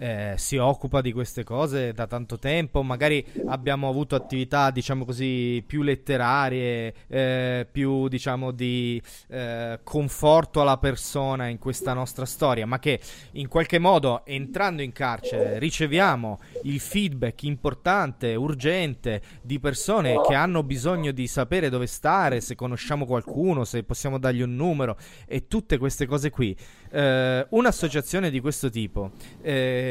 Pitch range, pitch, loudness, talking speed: 125-150 Hz, 135 Hz, -25 LUFS, 140 wpm